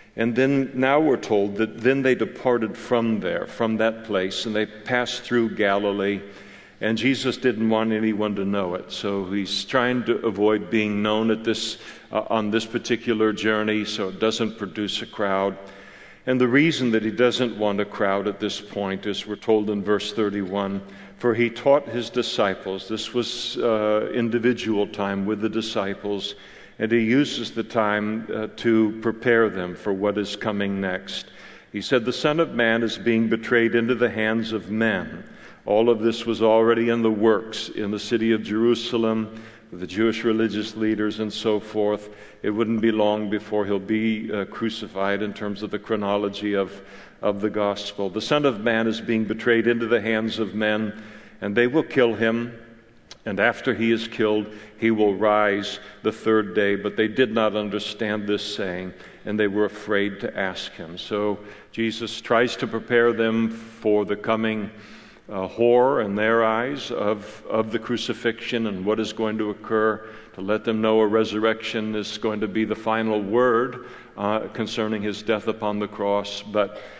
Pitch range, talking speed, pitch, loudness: 105-115 Hz, 180 wpm, 110 Hz, -23 LUFS